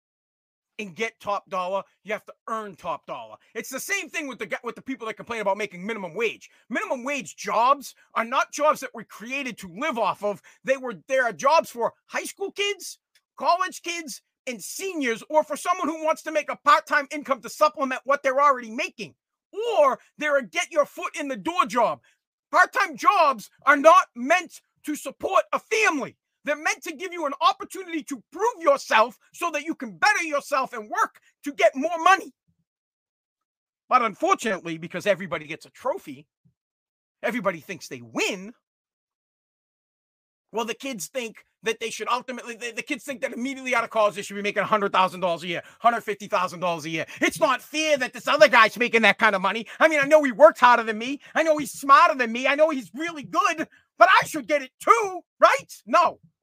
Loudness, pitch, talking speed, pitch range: -23 LUFS, 265 Hz, 200 wpm, 220-315 Hz